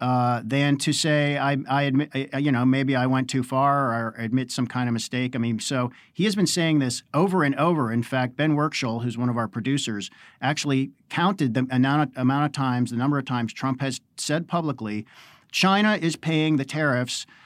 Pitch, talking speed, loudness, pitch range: 135 Hz, 205 wpm, -24 LUFS, 125-150 Hz